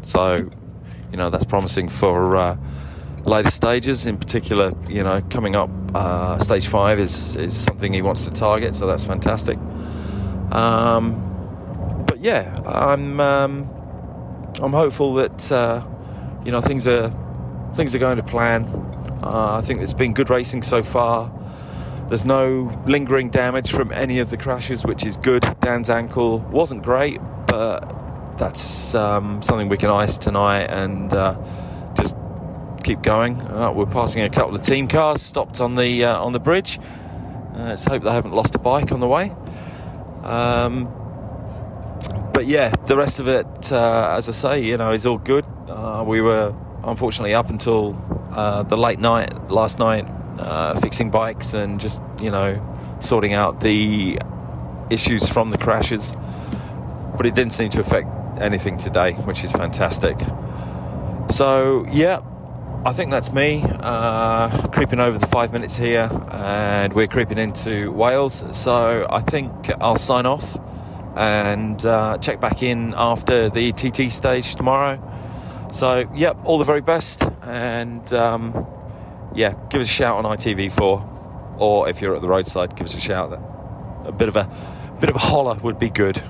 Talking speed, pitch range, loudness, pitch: 165 wpm, 100-125 Hz, -20 LUFS, 110 Hz